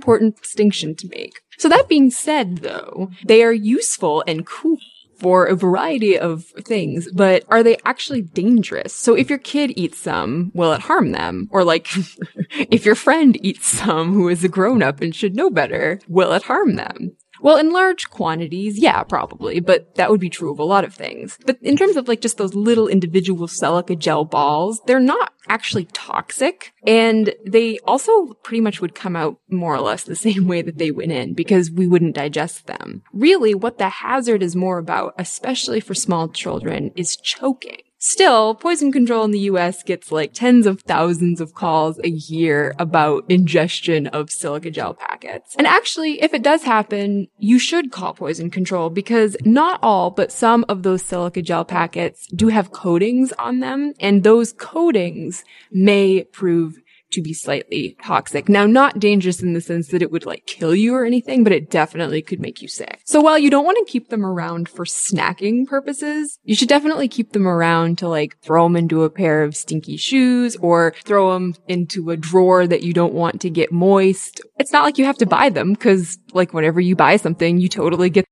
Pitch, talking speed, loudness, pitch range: 195 Hz, 195 wpm, -17 LUFS, 170-240 Hz